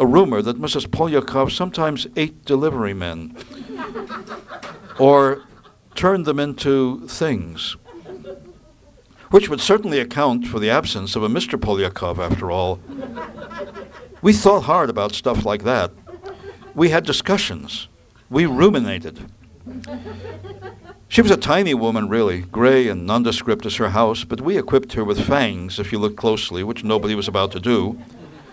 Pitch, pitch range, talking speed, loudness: 125 Hz, 105-155 Hz, 140 wpm, -19 LUFS